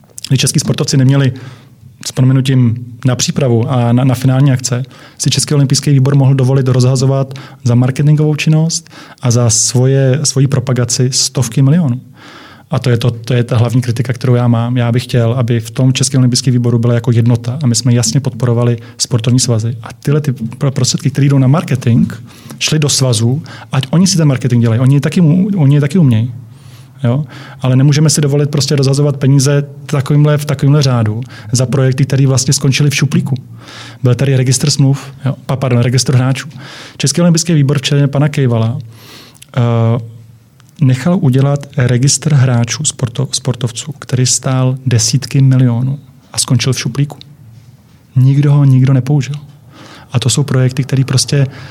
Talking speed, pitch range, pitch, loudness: 165 wpm, 125-140 Hz, 130 Hz, -12 LUFS